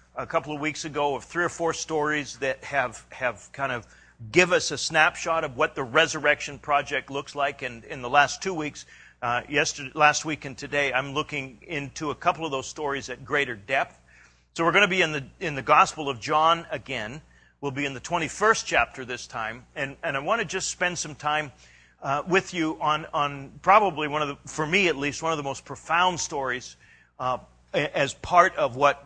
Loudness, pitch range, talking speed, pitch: -25 LUFS, 140-160 Hz, 220 wpm, 150 Hz